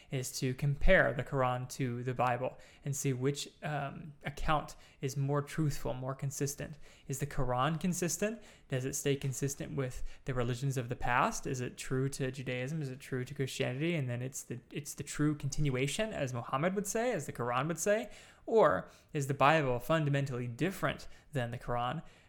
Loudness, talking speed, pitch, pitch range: -34 LUFS, 185 wpm, 140 Hz, 130-150 Hz